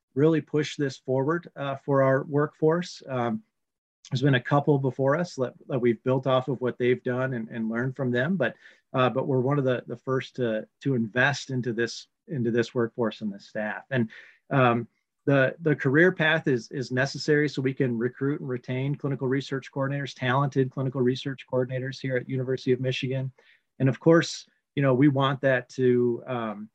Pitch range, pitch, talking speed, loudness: 125-140 Hz, 130 Hz, 195 wpm, -26 LUFS